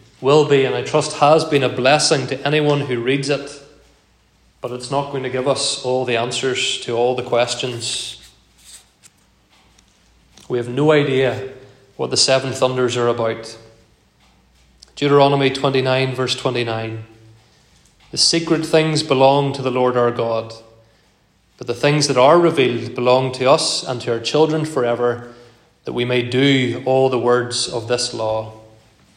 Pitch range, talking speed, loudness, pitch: 120-140 Hz, 155 wpm, -17 LUFS, 125 Hz